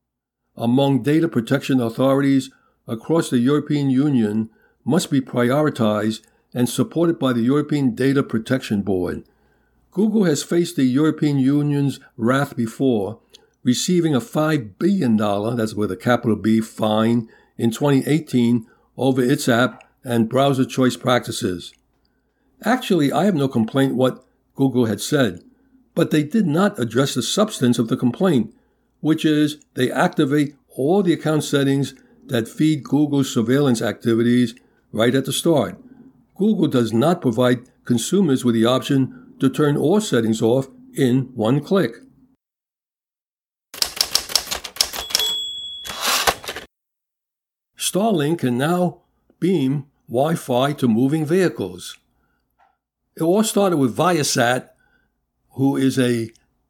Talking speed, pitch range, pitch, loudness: 125 wpm, 120-150 Hz, 135 Hz, -19 LUFS